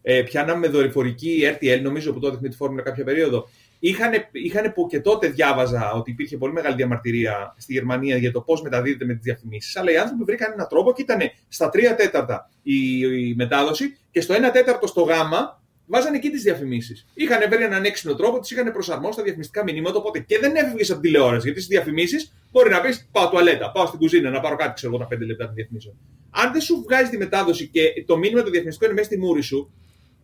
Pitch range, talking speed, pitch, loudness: 125-215 Hz, 220 wpm, 155 Hz, -21 LUFS